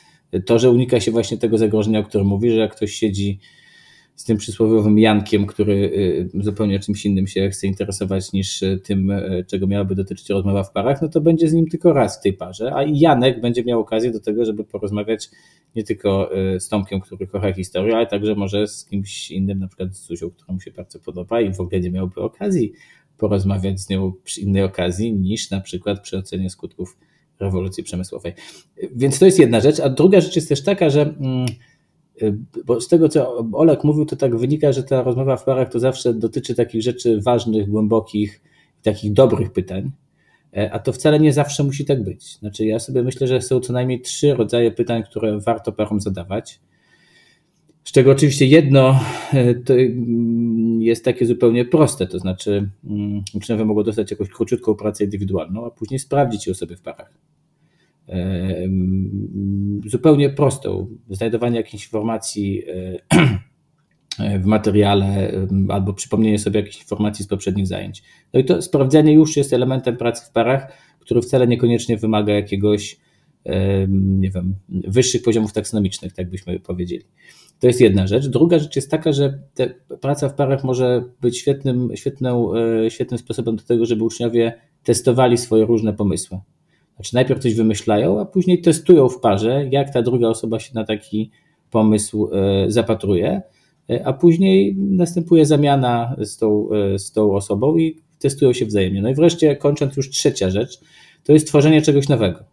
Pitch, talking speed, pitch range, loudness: 115 Hz, 165 wpm, 100-130 Hz, -18 LUFS